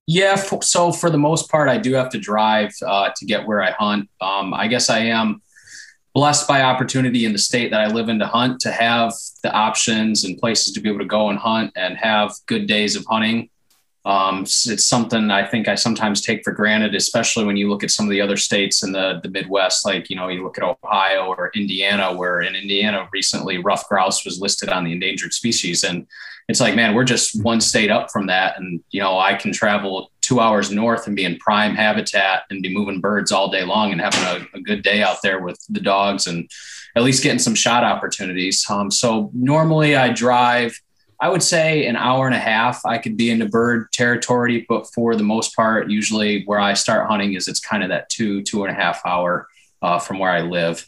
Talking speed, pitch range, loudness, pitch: 230 wpm, 95-120 Hz, -18 LUFS, 105 Hz